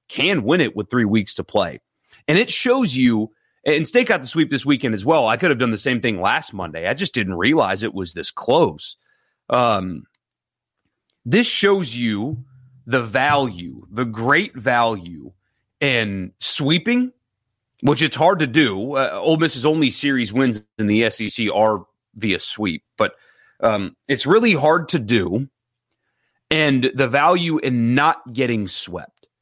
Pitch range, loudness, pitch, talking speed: 115-155 Hz, -19 LUFS, 130 Hz, 165 wpm